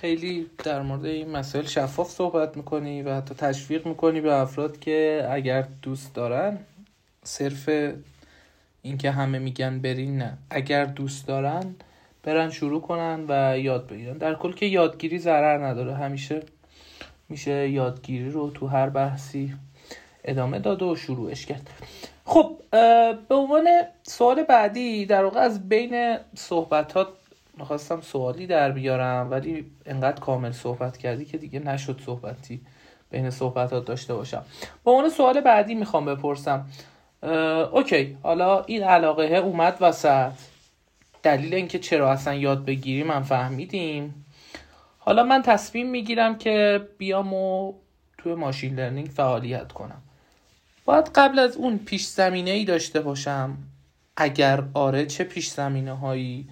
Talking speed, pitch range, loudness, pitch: 135 wpm, 135-180 Hz, -24 LUFS, 150 Hz